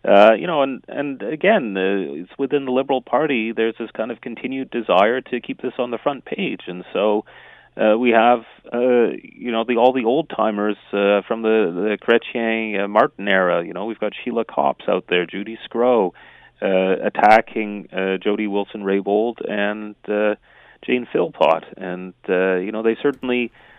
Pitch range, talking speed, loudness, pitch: 100-120 Hz, 175 wpm, -20 LUFS, 110 Hz